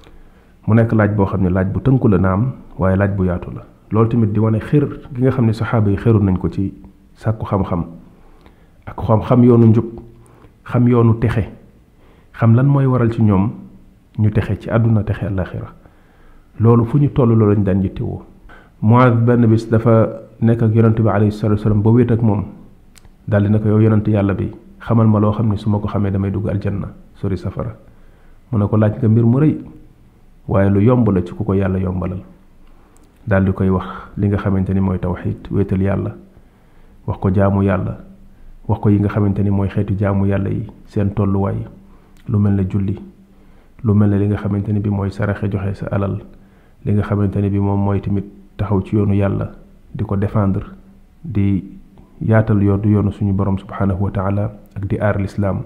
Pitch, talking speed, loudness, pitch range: 100 Hz, 75 wpm, -17 LUFS, 95-110 Hz